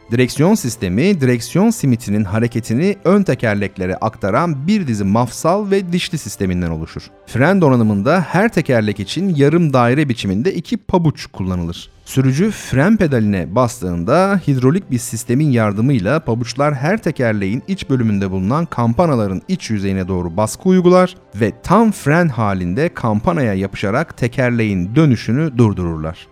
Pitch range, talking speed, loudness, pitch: 105-170 Hz, 125 wpm, -16 LUFS, 125 Hz